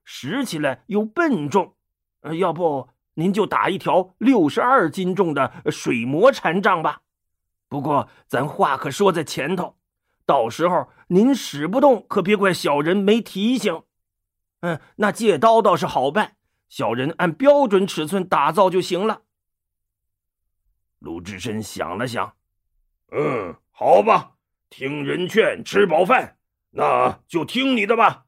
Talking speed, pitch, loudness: 190 characters per minute, 175 Hz, -20 LUFS